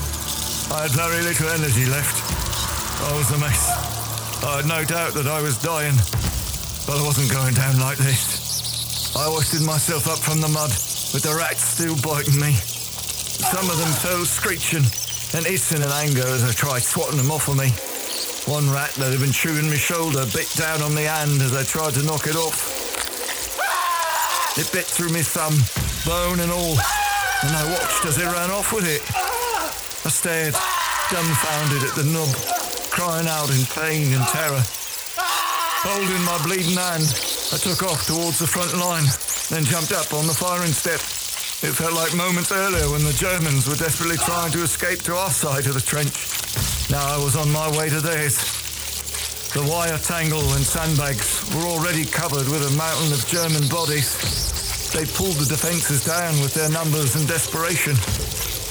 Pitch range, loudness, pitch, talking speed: 135-165 Hz, -20 LUFS, 150 Hz, 175 wpm